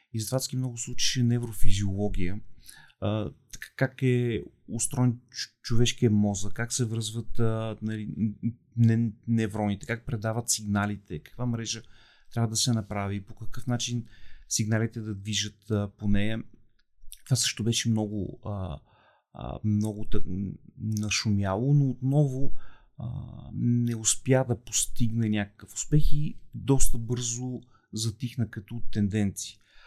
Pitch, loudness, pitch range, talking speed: 115 Hz, -29 LUFS, 105-120 Hz, 120 wpm